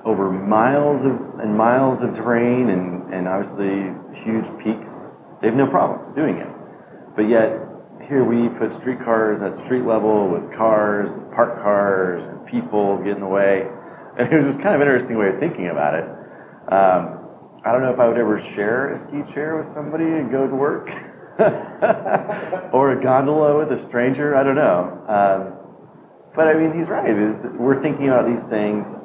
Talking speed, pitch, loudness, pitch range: 180 wpm, 115 Hz, -19 LUFS, 100-135 Hz